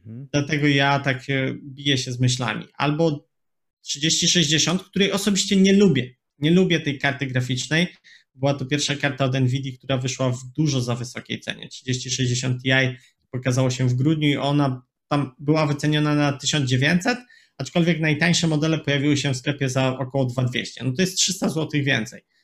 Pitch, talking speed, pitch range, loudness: 140 Hz, 160 wpm, 130-160 Hz, -22 LUFS